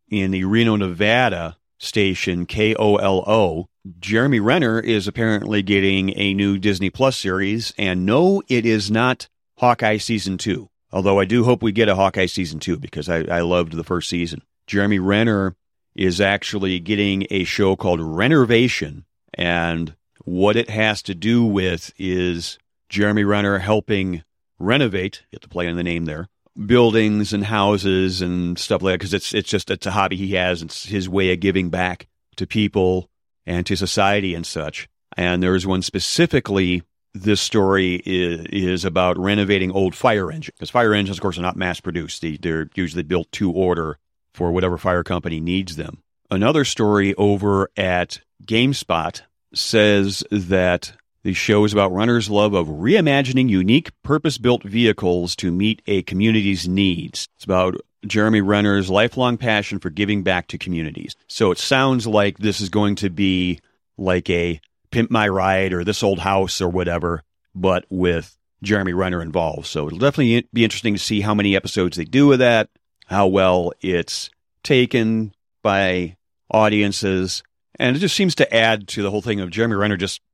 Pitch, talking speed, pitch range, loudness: 100 Hz, 170 wpm, 90-105 Hz, -19 LUFS